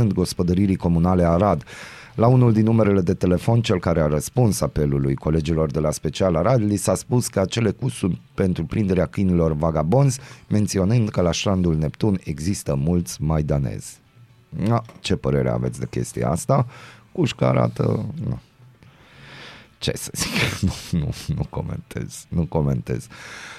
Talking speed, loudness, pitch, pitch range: 145 wpm, -21 LUFS, 95 Hz, 80-110 Hz